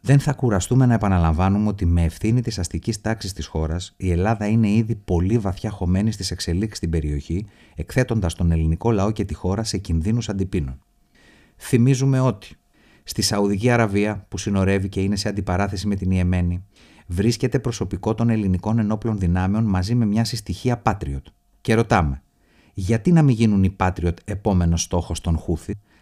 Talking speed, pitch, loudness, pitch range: 165 wpm, 100 Hz, -21 LUFS, 90-110 Hz